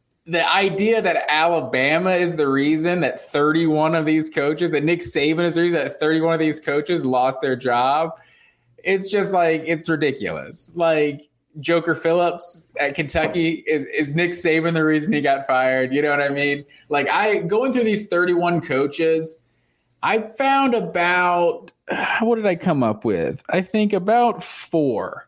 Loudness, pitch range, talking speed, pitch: -20 LUFS, 150-175 Hz, 165 wpm, 165 Hz